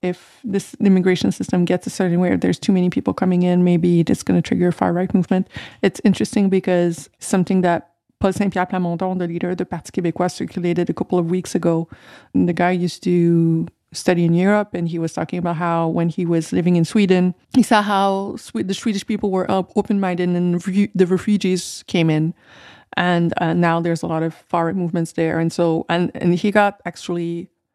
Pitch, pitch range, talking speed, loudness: 180 Hz, 170-190 Hz, 205 wpm, -19 LUFS